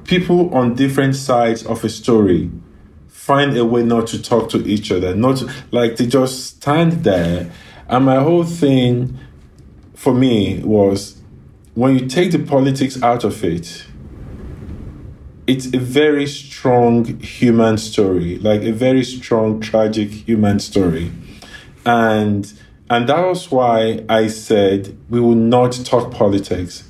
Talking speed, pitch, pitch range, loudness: 140 wpm, 115 Hz, 105-130 Hz, -16 LUFS